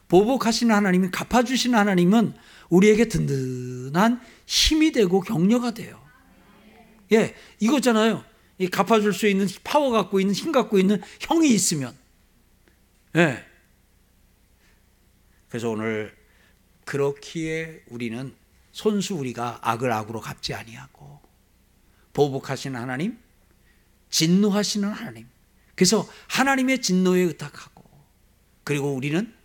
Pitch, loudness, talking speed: 185 Hz, -22 LUFS, 260 characters per minute